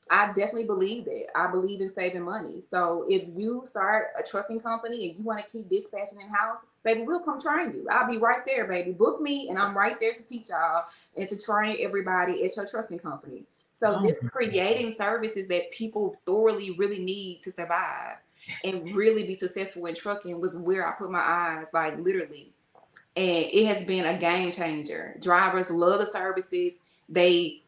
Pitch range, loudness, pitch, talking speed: 180-225 Hz, -27 LUFS, 195 Hz, 190 wpm